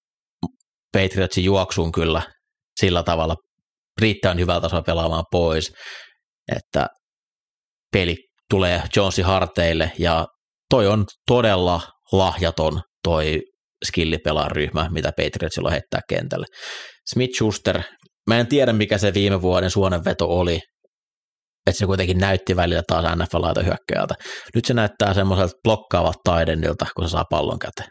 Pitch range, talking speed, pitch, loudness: 85-100 Hz, 125 wpm, 90 Hz, -21 LUFS